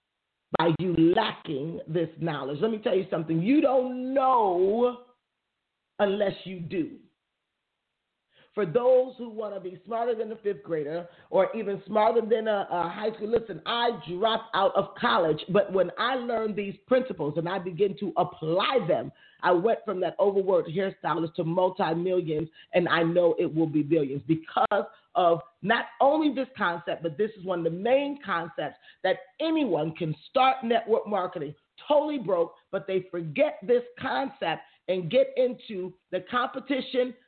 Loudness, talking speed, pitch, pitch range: -27 LUFS, 165 wpm, 200 Hz, 175-245 Hz